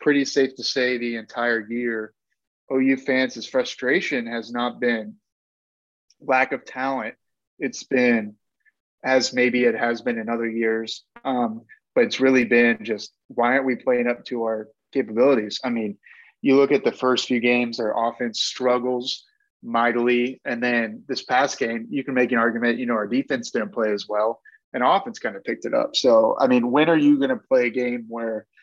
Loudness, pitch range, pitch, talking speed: -22 LUFS, 115-130 Hz, 120 Hz, 190 wpm